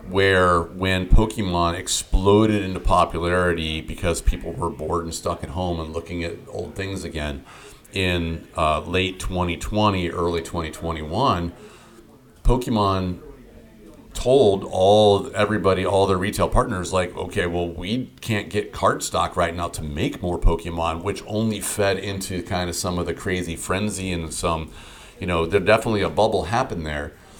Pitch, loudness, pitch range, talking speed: 90 Hz, -22 LUFS, 85-100 Hz, 150 wpm